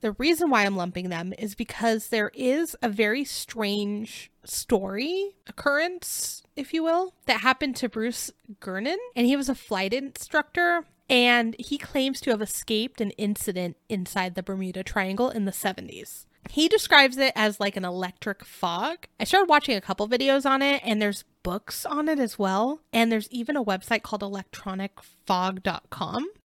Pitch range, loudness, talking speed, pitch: 200-280 Hz, -25 LUFS, 170 wpm, 235 Hz